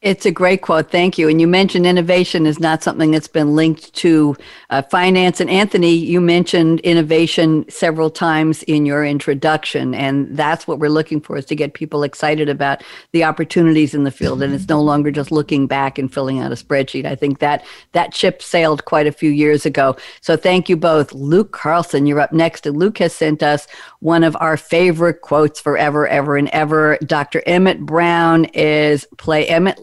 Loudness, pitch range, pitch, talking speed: -15 LUFS, 145-170 Hz, 155 Hz, 195 wpm